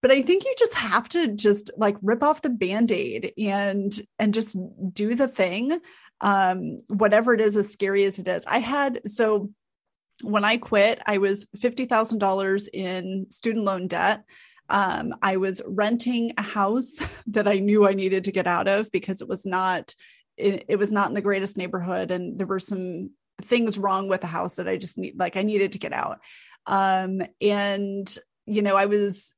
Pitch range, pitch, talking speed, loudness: 195-225 Hz, 205 Hz, 190 wpm, -24 LUFS